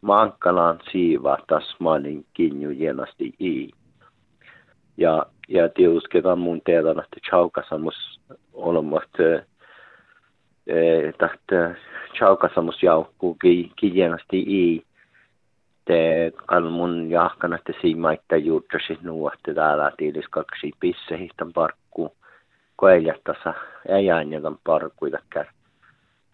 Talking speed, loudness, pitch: 90 wpm, -22 LUFS, 85 Hz